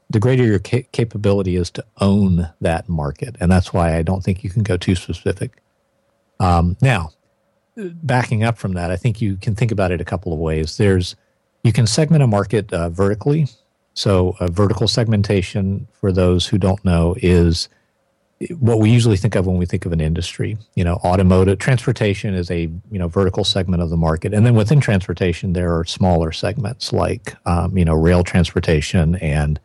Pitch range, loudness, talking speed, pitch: 90-110 Hz, -18 LUFS, 190 wpm, 95 Hz